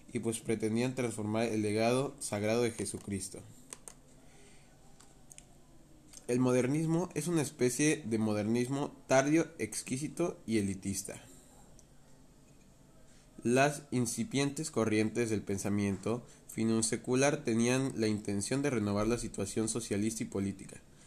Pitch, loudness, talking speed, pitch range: 115 Hz, -33 LUFS, 105 wpm, 105-135 Hz